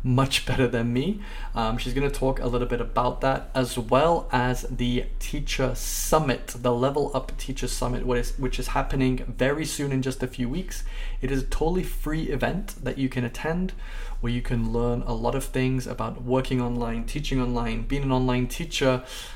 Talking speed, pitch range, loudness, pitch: 200 wpm, 125-135 Hz, -27 LUFS, 130 Hz